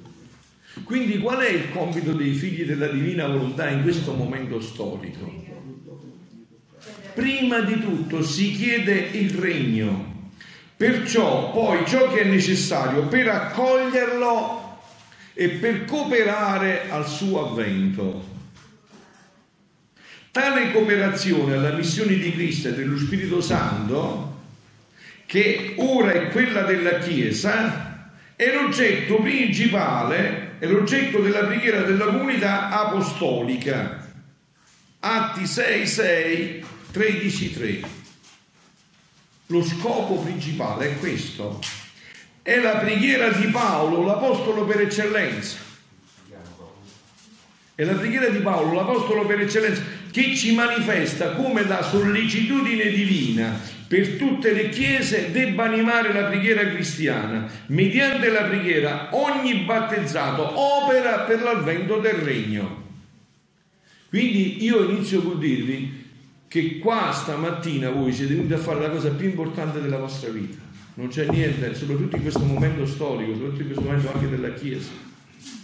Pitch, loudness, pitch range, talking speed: 190 Hz, -22 LUFS, 155-220 Hz, 115 wpm